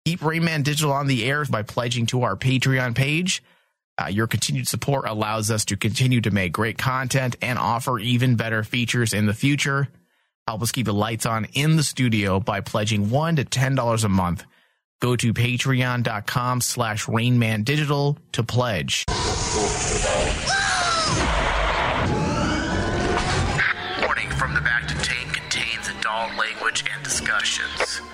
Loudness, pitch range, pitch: -22 LUFS, 110-135 Hz, 125 Hz